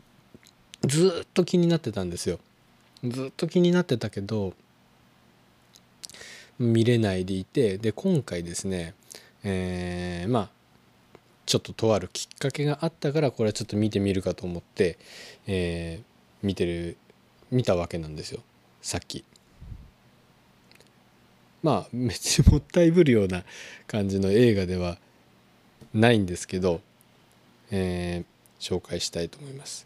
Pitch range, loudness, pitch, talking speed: 85-120 Hz, -26 LUFS, 95 Hz, 265 characters per minute